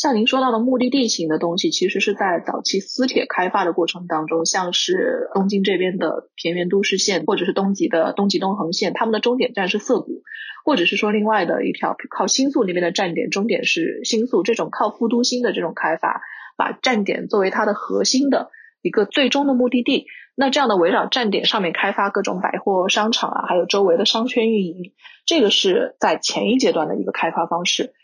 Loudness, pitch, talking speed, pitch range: -19 LUFS, 210 Hz, 330 characters per minute, 185-250 Hz